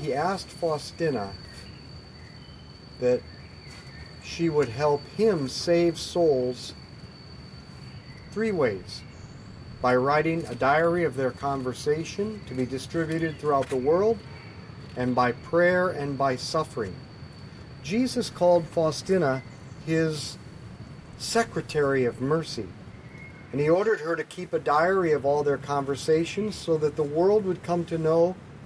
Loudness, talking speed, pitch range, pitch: -26 LUFS, 120 wpm, 130-170 Hz, 150 Hz